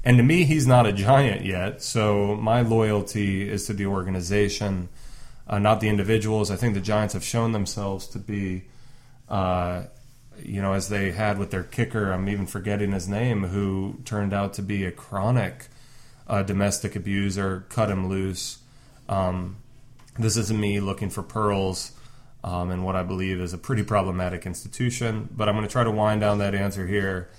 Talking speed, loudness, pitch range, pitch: 180 wpm, -25 LUFS, 95-115 Hz, 105 Hz